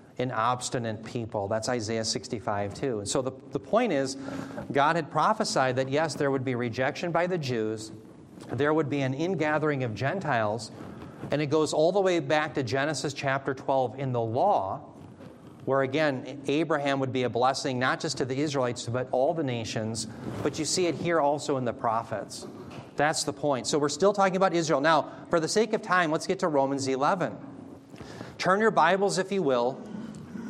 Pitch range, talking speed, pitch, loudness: 130-160 Hz, 190 wpm, 140 Hz, -27 LUFS